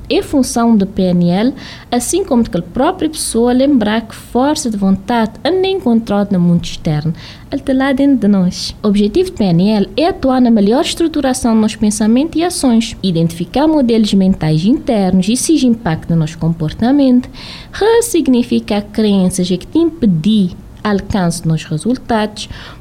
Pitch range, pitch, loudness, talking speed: 185-265 Hz, 225 Hz, -13 LUFS, 165 wpm